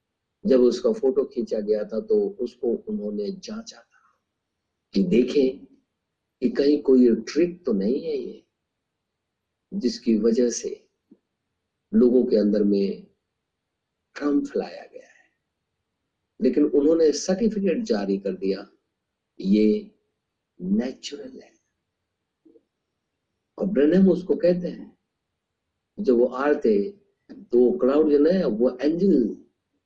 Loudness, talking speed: -22 LUFS, 110 wpm